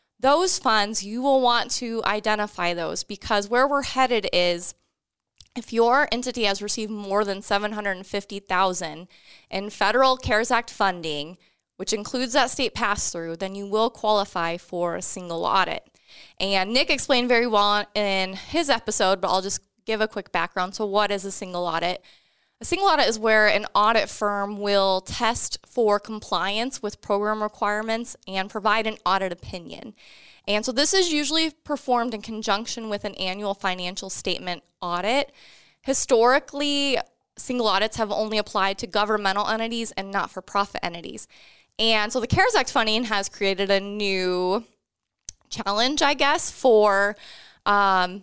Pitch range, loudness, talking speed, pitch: 195-235 Hz, -23 LUFS, 160 wpm, 210 Hz